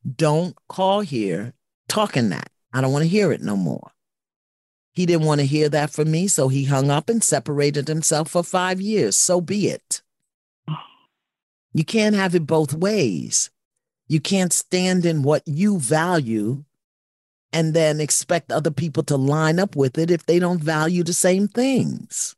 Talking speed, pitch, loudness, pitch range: 170 wpm, 160 Hz, -20 LUFS, 145-180 Hz